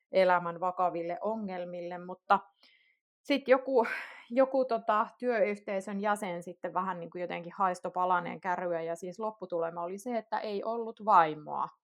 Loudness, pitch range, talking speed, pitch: -31 LUFS, 180-220 Hz, 130 wpm, 185 Hz